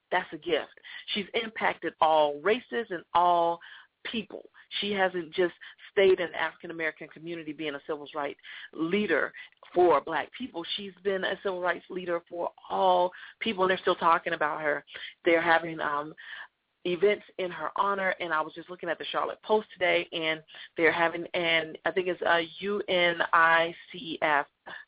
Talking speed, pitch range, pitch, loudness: 165 wpm, 165-200 Hz, 175 Hz, -28 LUFS